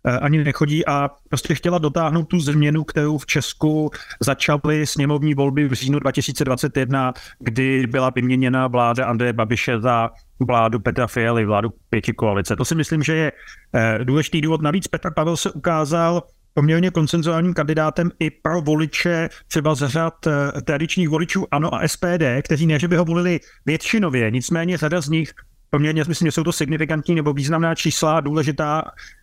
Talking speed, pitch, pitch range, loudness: 160 wpm, 155 Hz, 130-165 Hz, -20 LUFS